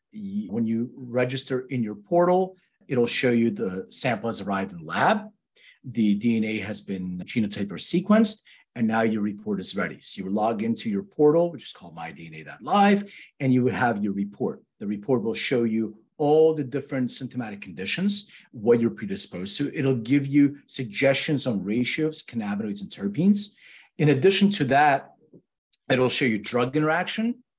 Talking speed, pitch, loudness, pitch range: 170 wpm, 130 Hz, -24 LUFS, 110-180 Hz